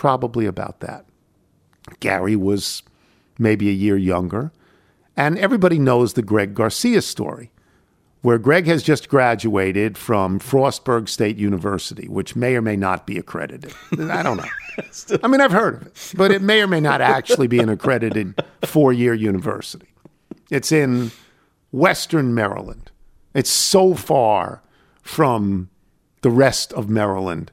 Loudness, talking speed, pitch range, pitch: -18 LUFS, 145 wpm, 100-140 Hz, 115 Hz